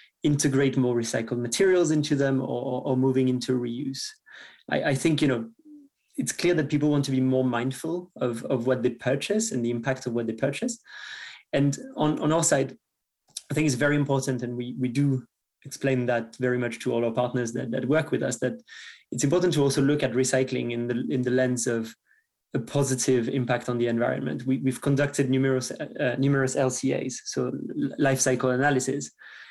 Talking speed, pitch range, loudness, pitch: 195 wpm, 125-145 Hz, -26 LUFS, 130 Hz